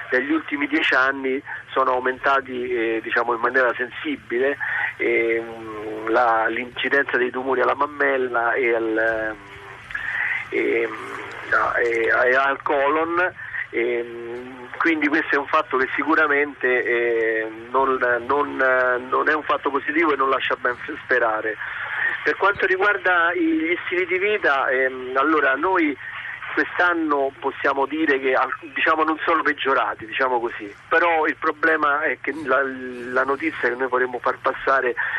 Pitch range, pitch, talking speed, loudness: 120-160 Hz, 130 Hz, 135 wpm, -21 LUFS